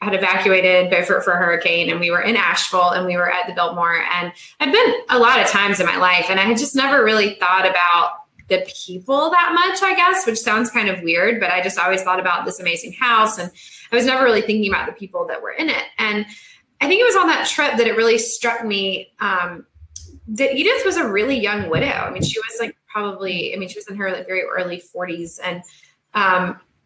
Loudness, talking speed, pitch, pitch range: -17 LUFS, 240 wpm, 195 Hz, 180-240 Hz